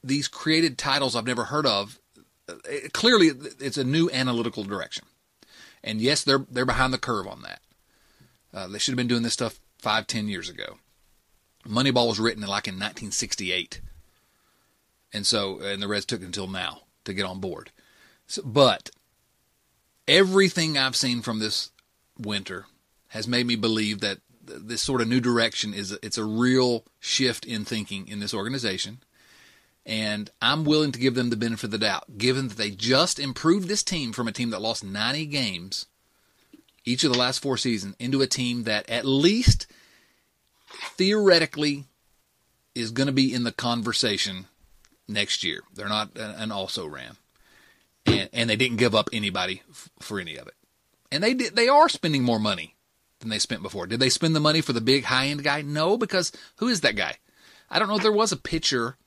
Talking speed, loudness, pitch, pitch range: 180 wpm, -24 LUFS, 120 Hz, 105-135 Hz